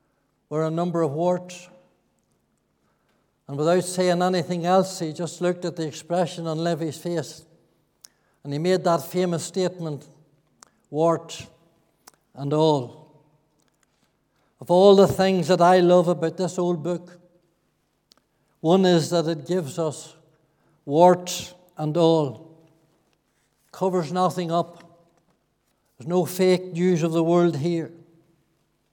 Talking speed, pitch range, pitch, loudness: 125 wpm, 155-180 Hz, 170 Hz, -22 LUFS